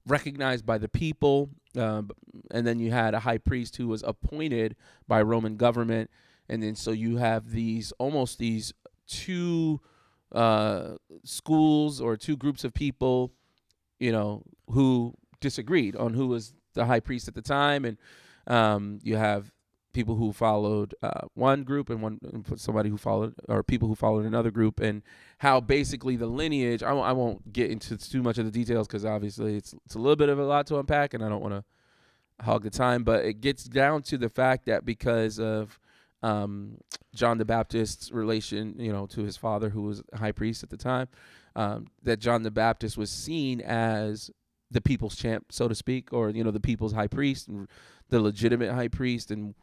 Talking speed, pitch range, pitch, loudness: 190 wpm, 110-130 Hz, 115 Hz, -28 LUFS